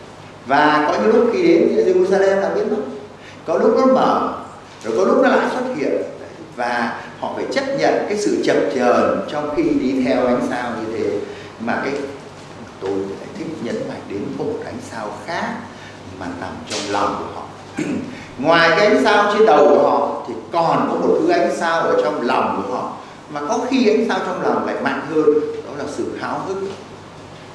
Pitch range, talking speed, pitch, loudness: 140-240 Hz, 200 wpm, 185 Hz, -18 LUFS